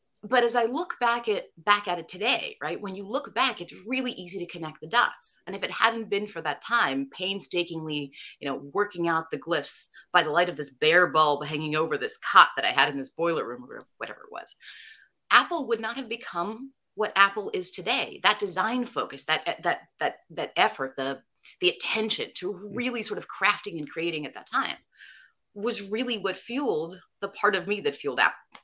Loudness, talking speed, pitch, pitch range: -26 LUFS, 210 wpm, 200 Hz, 160-235 Hz